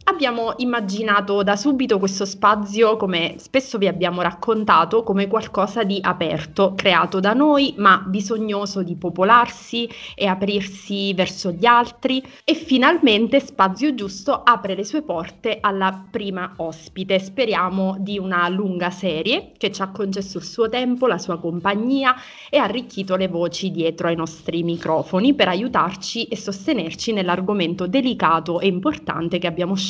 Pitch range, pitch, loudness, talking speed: 185-235 Hz, 200 Hz, -20 LUFS, 145 wpm